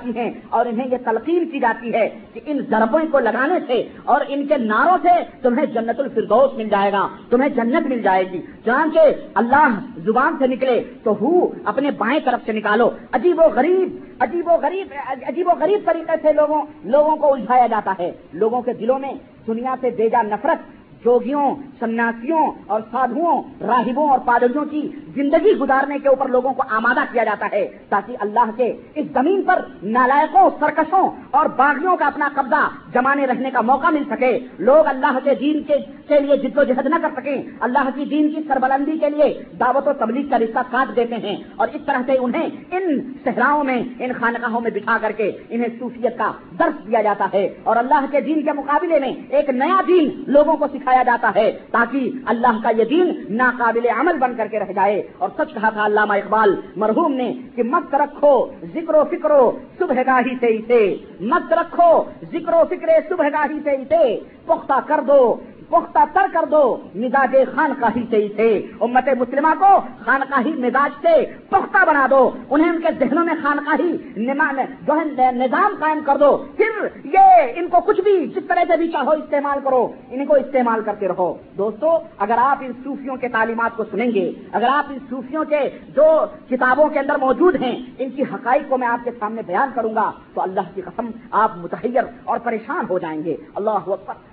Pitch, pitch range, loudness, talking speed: 270 Hz, 235-305 Hz, -18 LUFS, 190 wpm